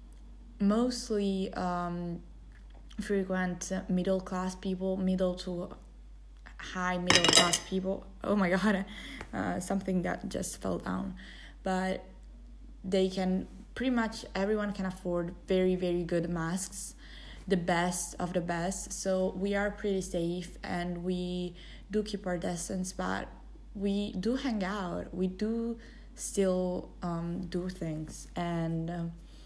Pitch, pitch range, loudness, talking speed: 185 Hz, 175-200 Hz, -32 LUFS, 125 wpm